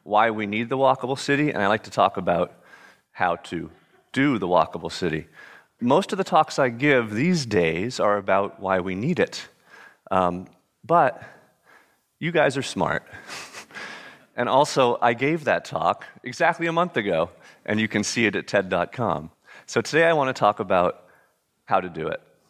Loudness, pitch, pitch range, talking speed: -23 LUFS, 120 Hz, 105-155 Hz, 175 wpm